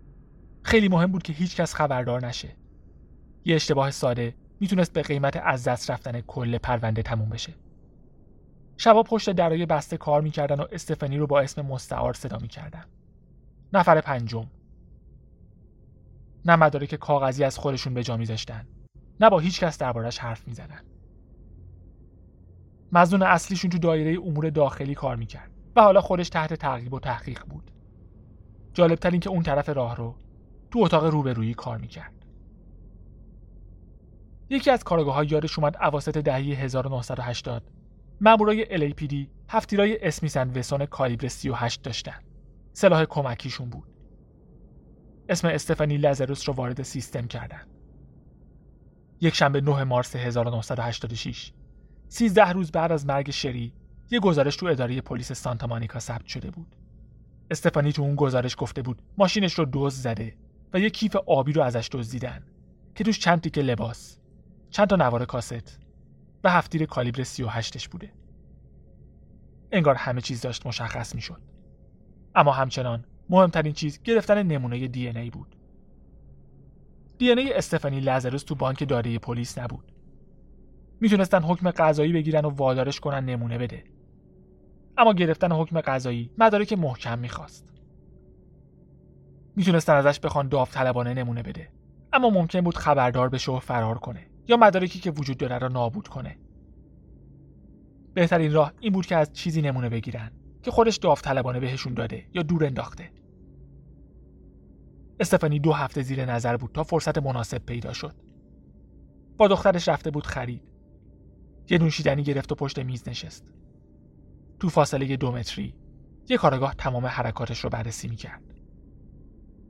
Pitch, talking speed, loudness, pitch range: 135 Hz, 140 wpm, -24 LUFS, 115-160 Hz